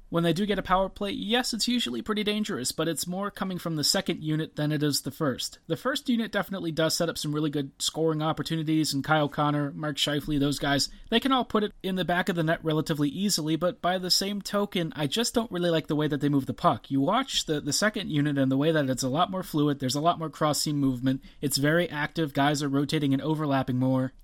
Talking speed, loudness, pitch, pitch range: 260 wpm, -27 LUFS, 160 Hz, 145-185 Hz